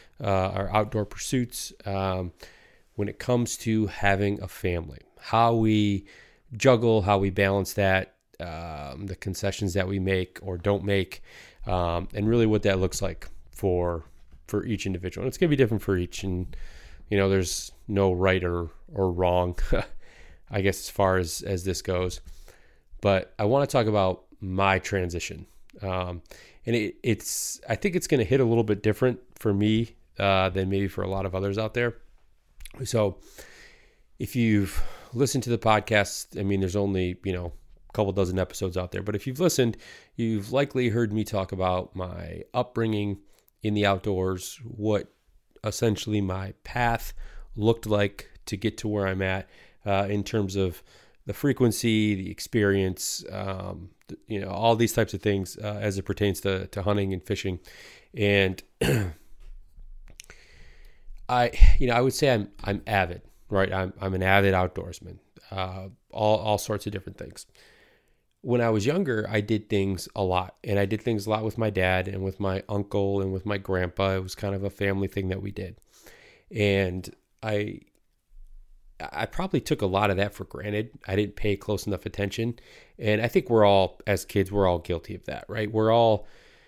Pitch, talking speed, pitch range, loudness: 100 Hz, 180 wpm, 95-110 Hz, -26 LUFS